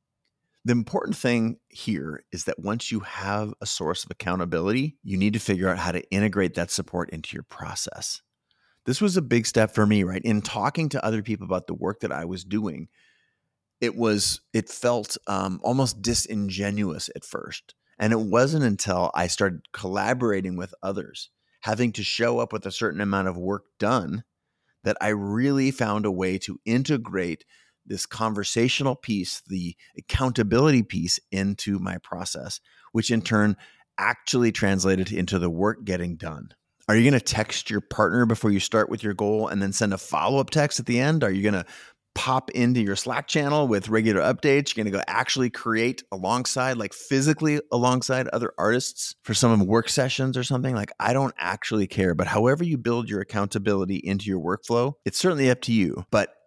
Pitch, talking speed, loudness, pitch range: 110 Hz, 185 wpm, -25 LUFS, 100-125 Hz